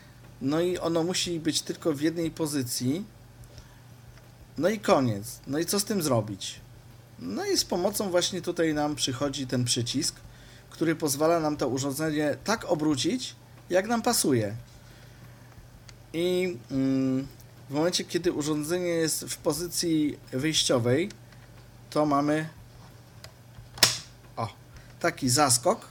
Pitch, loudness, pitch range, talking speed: 135 Hz, -27 LUFS, 120-165 Hz, 120 wpm